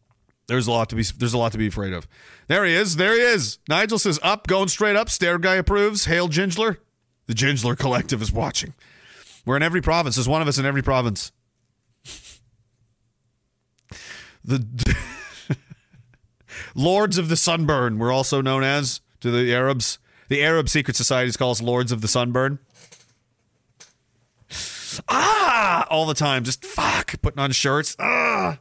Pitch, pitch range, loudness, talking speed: 130 Hz, 120-160 Hz, -21 LUFS, 160 wpm